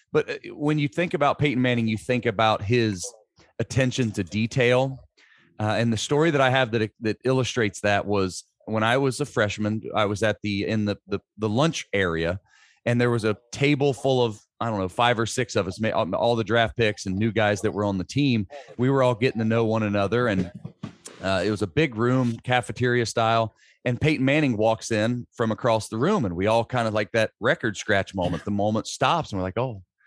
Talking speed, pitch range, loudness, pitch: 220 wpm, 105-130 Hz, -24 LUFS, 115 Hz